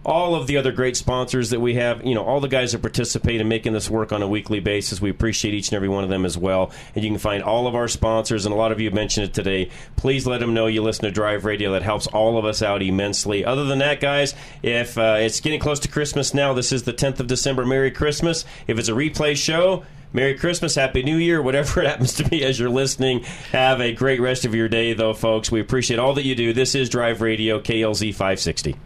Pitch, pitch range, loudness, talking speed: 120 Hz, 110-135 Hz, -21 LUFS, 260 wpm